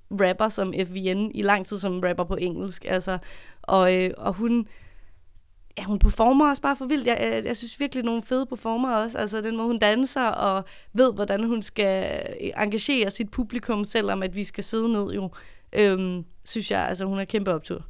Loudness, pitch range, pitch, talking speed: -25 LUFS, 190-230 Hz, 205 Hz, 200 wpm